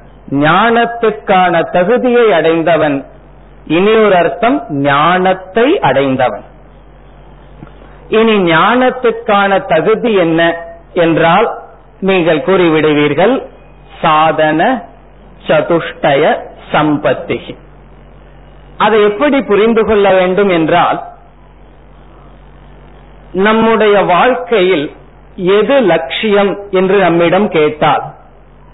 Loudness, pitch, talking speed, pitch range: -10 LUFS, 185 Hz, 60 wpm, 160-215 Hz